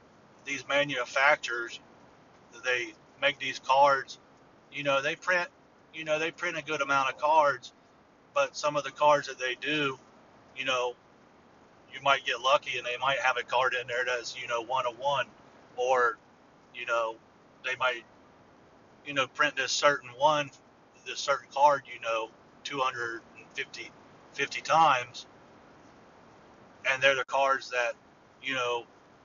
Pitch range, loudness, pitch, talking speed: 120-145 Hz, -29 LUFS, 135 Hz, 150 wpm